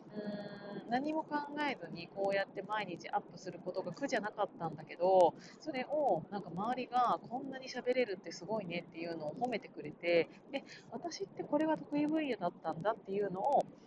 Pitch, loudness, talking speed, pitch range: 205 Hz, -37 LUFS, 395 characters per minute, 175-250 Hz